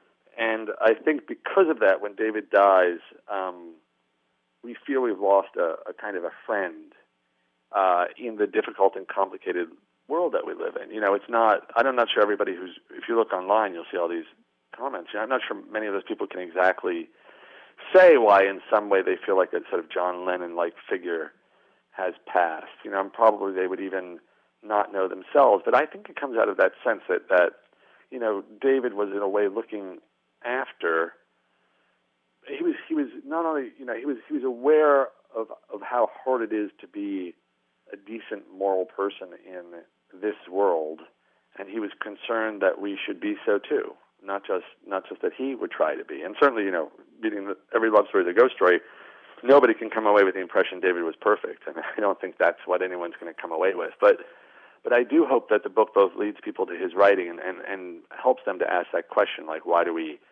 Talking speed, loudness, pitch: 215 wpm, -24 LUFS, 150 Hz